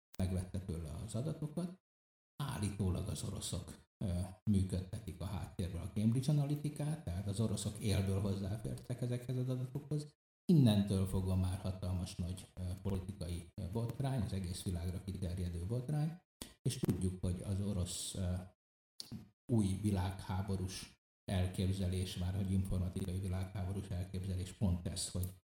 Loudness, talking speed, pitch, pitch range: -39 LUFS, 115 wpm, 95 Hz, 90-110 Hz